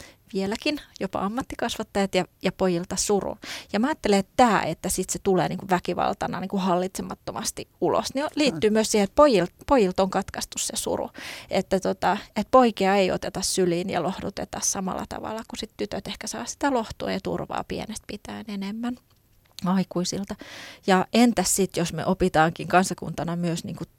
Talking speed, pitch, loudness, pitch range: 165 wpm, 195 Hz, -25 LUFS, 180-225 Hz